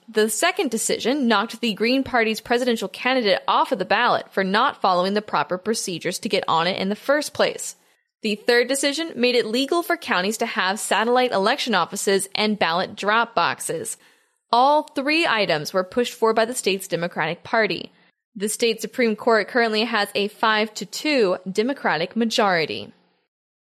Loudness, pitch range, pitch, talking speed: -21 LUFS, 200-255 Hz, 225 Hz, 170 wpm